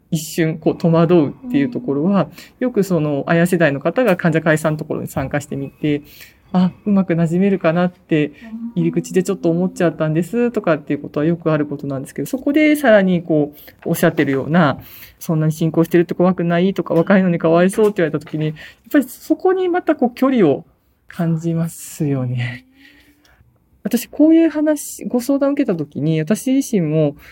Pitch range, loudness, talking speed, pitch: 155-215 Hz, -17 LUFS, 405 characters per minute, 170 Hz